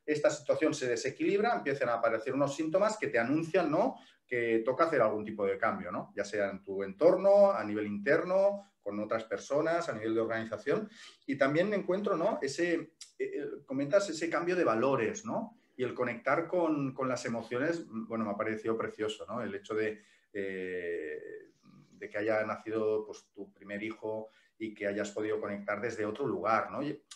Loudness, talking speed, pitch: -32 LUFS, 185 wpm, 115 Hz